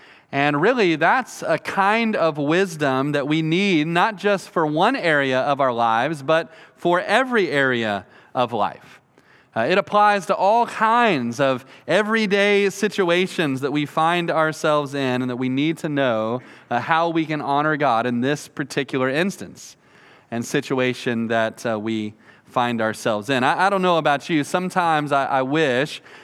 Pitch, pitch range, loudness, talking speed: 150 Hz, 130-175 Hz, -20 LUFS, 165 wpm